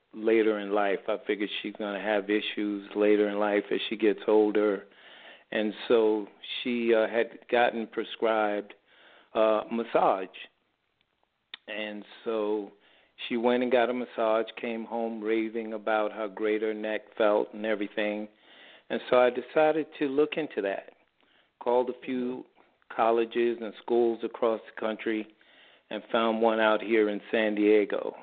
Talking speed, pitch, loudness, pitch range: 150 wpm, 110 Hz, -28 LUFS, 105-115 Hz